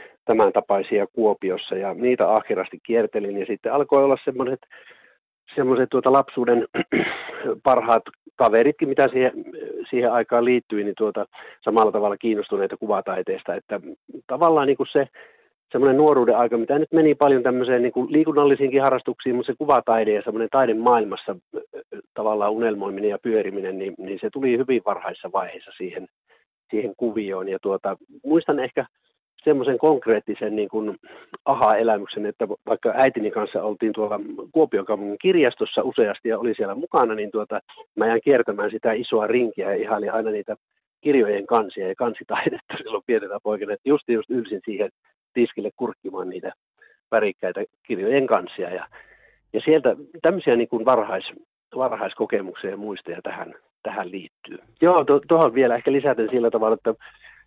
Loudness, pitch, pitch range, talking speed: -22 LUFS, 125 Hz, 110-150 Hz, 145 wpm